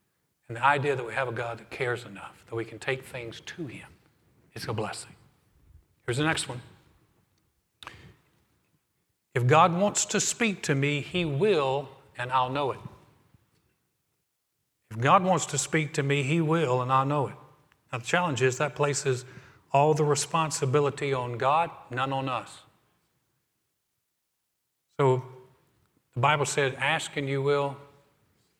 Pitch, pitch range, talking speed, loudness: 140 Hz, 130-150 Hz, 155 wpm, -27 LUFS